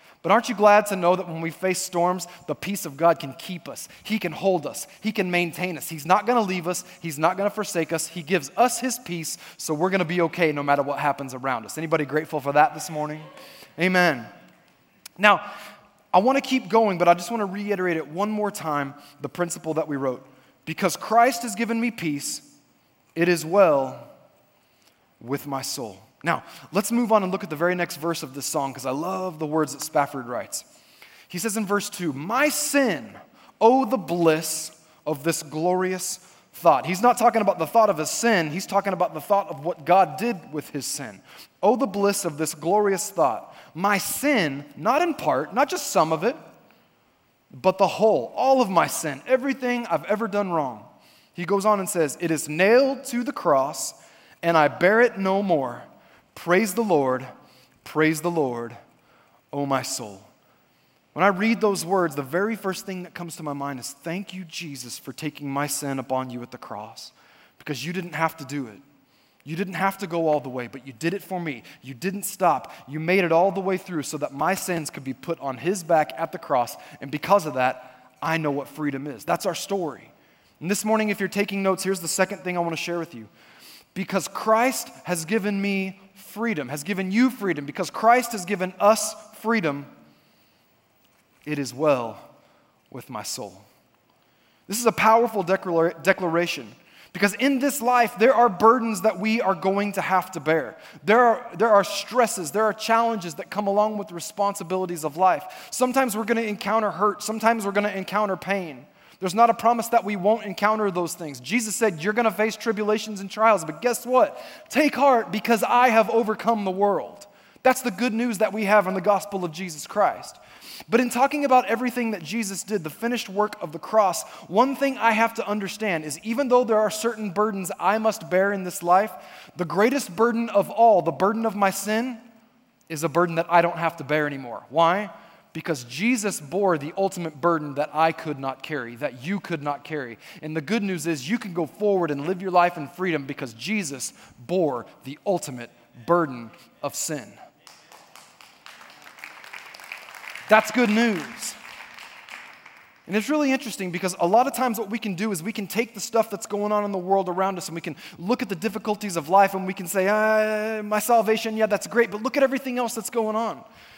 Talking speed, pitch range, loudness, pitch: 210 wpm, 160-215 Hz, -23 LUFS, 190 Hz